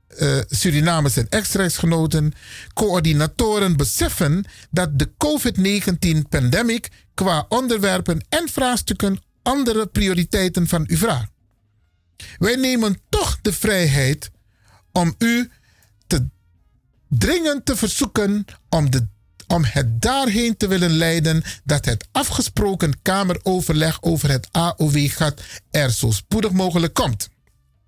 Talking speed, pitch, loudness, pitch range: 110 wpm, 165 Hz, -19 LUFS, 135-205 Hz